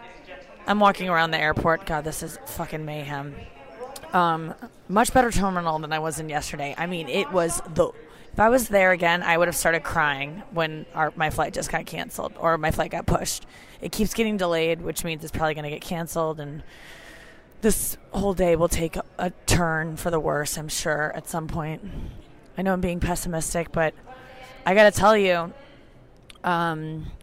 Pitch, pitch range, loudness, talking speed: 165 Hz, 155-185 Hz, -24 LUFS, 190 wpm